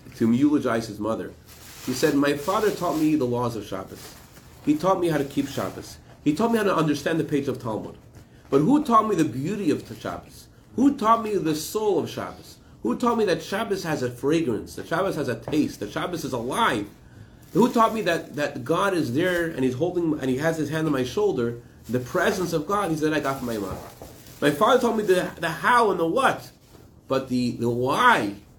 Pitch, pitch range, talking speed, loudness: 155 Hz, 125-195 Hz, 225 wpm, -24 LUFS